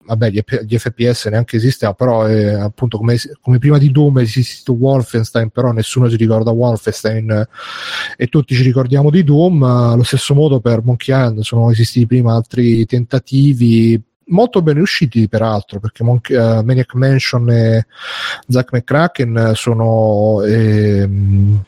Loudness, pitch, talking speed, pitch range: -13 LUFS, 120 Hz, 155 wpm, 110-130 Hz